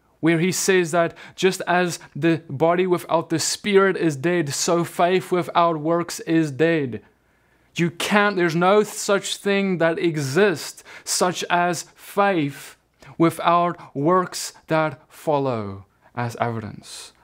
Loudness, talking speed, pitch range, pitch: -21 LUFS, 125 wpm, 155-180 Hz, 170 Hz